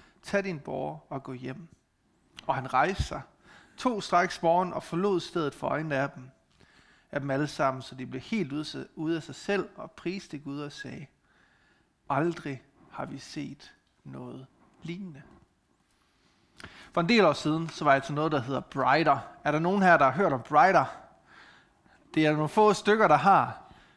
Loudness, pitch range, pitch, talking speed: -27 LUFS, 140-180 Hz, 155 Hz, 180 wpm